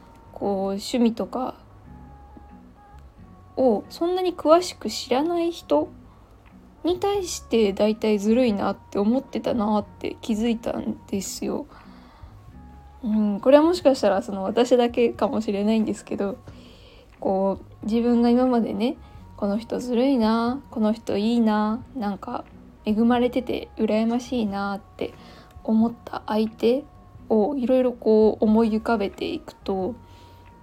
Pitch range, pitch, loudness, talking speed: 195-250 Hz, 220 Hz, -23 LUFS, 260 characters per minute